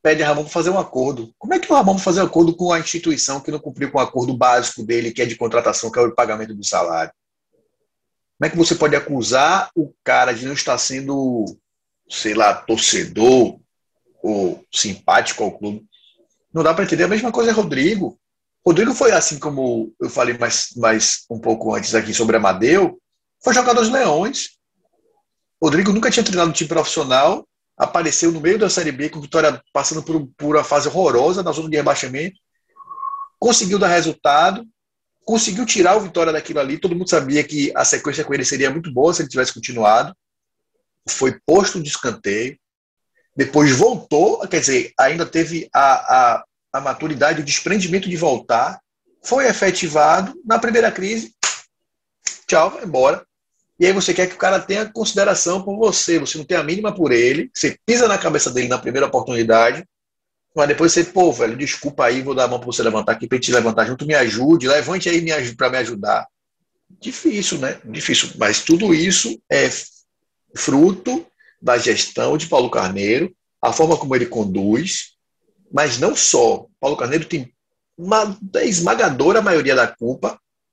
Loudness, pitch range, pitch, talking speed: -17 LUFS, 135-195 Hz, 160 Hz, 175 wpm